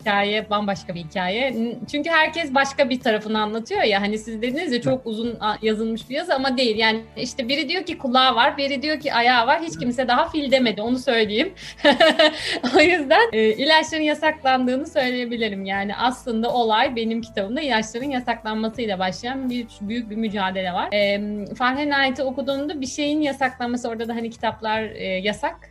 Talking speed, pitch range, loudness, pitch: 170 wpm, 220-275 Hz, -21 LUFS, 245 Hz